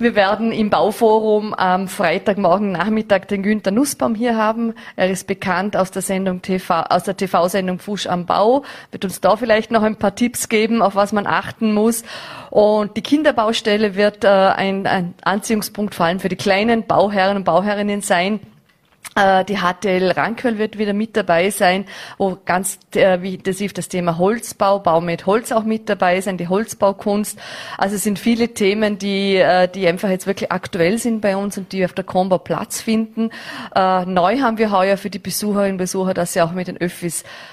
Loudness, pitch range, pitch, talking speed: -18 LUFS, 185-215 Hz, 200 Hz, 185 wpm